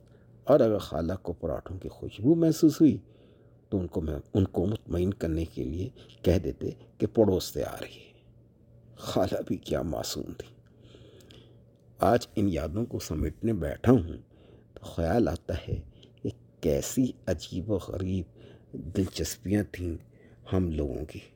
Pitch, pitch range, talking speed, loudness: 95 Hz, 80-110 Hz, 150 wpm, -29 LUFS